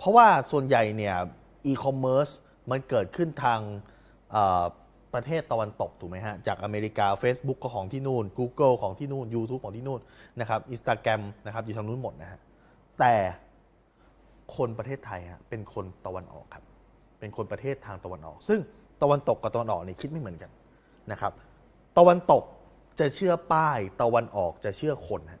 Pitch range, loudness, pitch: 105-135 Hz, -27 LUFS, 120 Hz